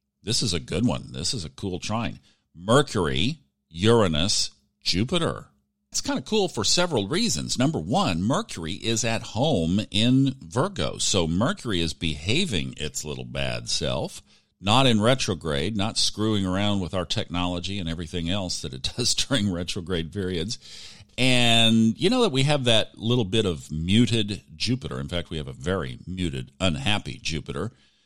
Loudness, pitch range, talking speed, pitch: -24 LUFS, 80-115 Hz, 160 wpm, 95 Hz